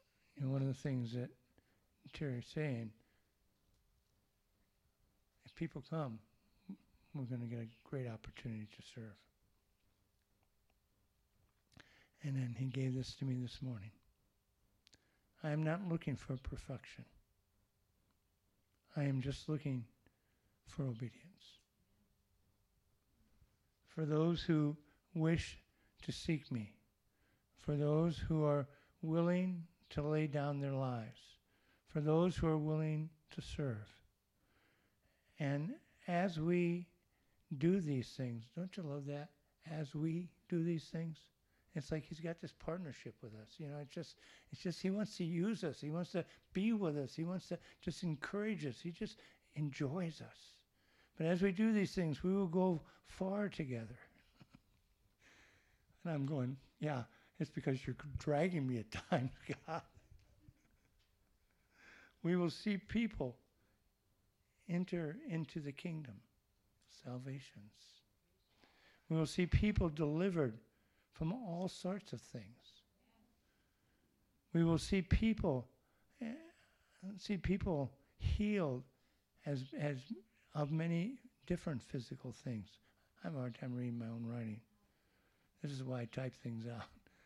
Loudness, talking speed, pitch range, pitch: -41 LUFS, 130 wpm, 115-165 Hz, 145 Hz